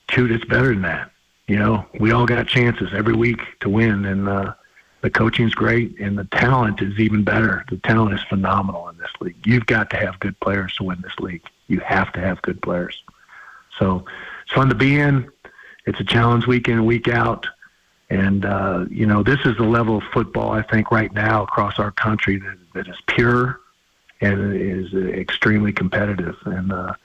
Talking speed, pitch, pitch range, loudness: 200 wpm, 110 Hz, 100-115 Hz, -19 LUFS